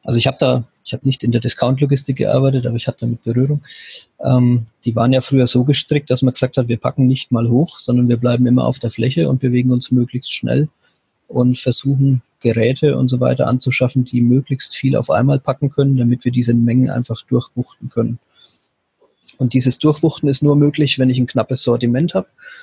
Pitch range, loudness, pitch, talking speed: 120-135 Hz, -16 LUFS, 130 Hz, 205 wpm